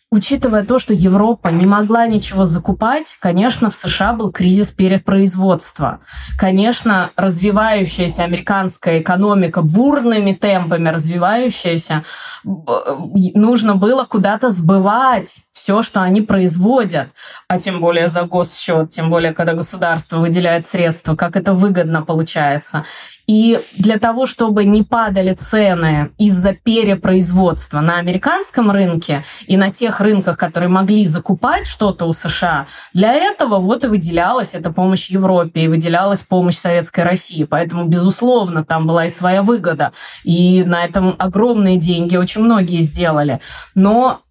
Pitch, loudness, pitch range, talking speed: 190 Hz, -14 LUFS, 170-210 Hz, 130 wpm